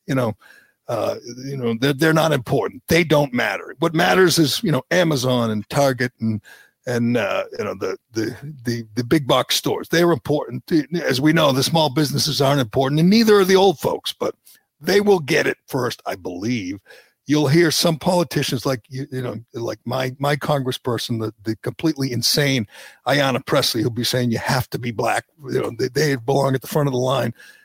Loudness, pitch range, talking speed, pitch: -20 LUFS, 125-160 Hz, 200 wpm, 140 Hz